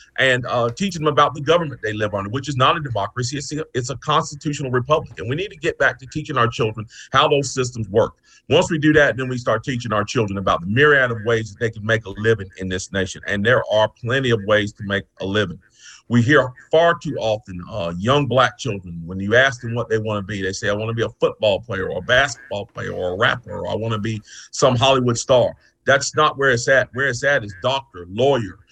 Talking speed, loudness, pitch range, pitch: 250 wpm, -19 LUFS, 105-140 Hz, 120 Hz